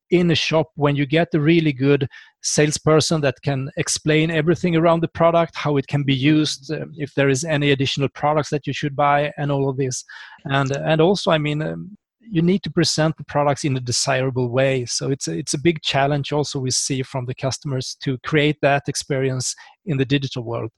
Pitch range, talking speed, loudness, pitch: 135-160 Hz, 210 wpm, -20 LUFS, 145 Hz